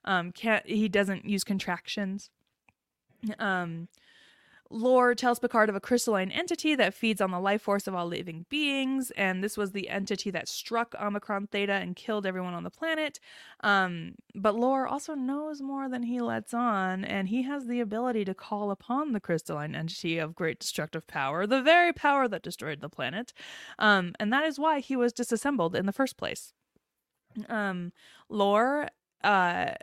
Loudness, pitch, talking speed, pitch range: -29 LUFS, 210 Hz, 175 wpm, 190-250 Hz